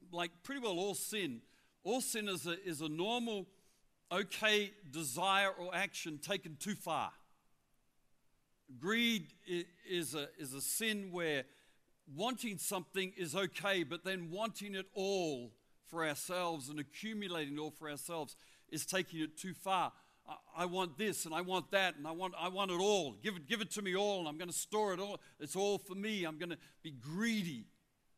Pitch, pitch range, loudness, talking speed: 185 Hz, 160-200 Hz, -39 LUFS, 185 wpm